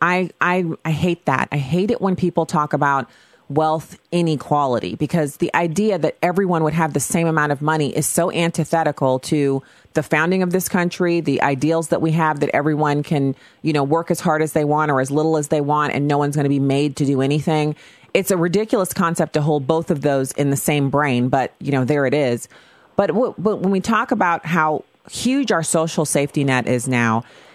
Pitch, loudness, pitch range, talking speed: 155 Hz, -19 LUFS, 145-170 Hz, 225 wpm